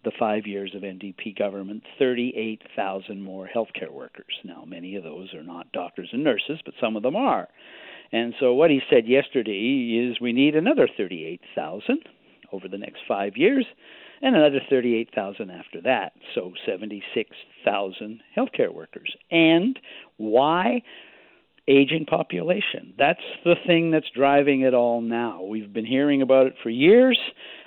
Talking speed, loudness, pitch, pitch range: 145 wpm, -23 LUFS, 130 Hz, 110-160 Hz